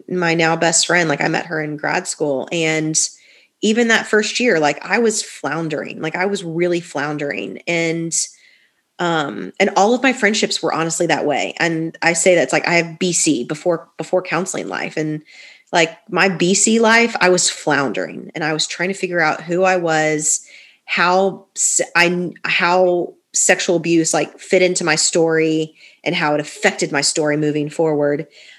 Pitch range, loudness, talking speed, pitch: 155-190 Hz, -17 LUFS, 180 wpm, 170 Hz